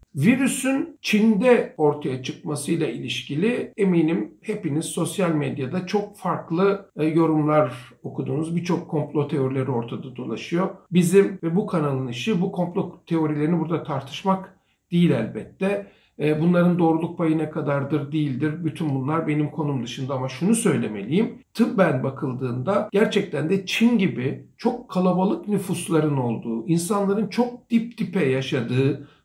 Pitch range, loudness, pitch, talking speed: 150-195 Hz, -23 LUFS, 165 Hz, 120 wpm